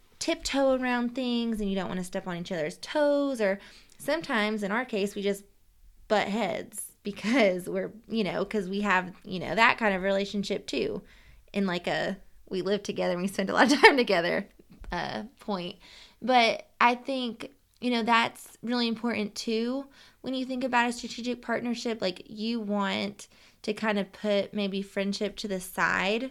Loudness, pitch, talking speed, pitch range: -28 LUFS, 210 Hz, 180 wpm, 195-240 Hz